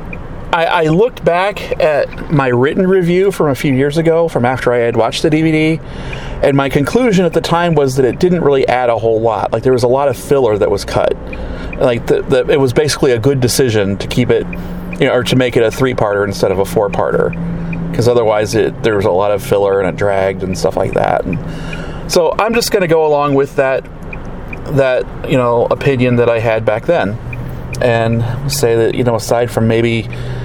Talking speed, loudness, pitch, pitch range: 210 wpm, -13 LUFS, 130 Hz, 115-155 Hz